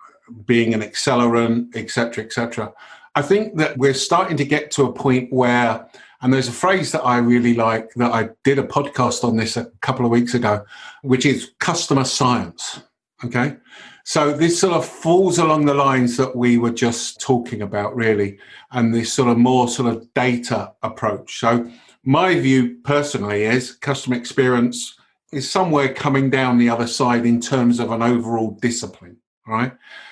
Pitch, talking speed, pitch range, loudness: 125 Hz, 180 wpm, 120-140 Hz, -19 LUFS